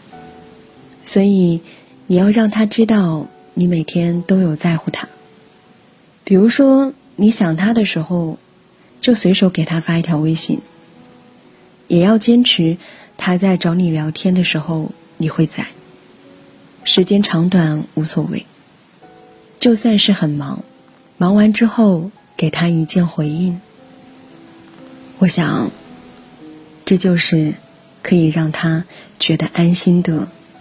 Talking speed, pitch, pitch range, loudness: 170 characters per minute, 175 Hz, 160-200 Hz, -15 LUFS